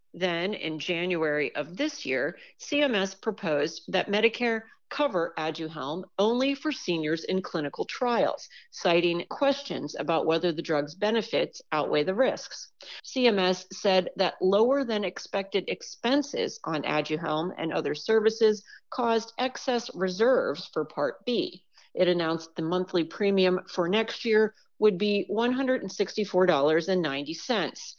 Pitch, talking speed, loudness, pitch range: 195 Hz, 120 wpm, -27 LUFS, 170-230 Hz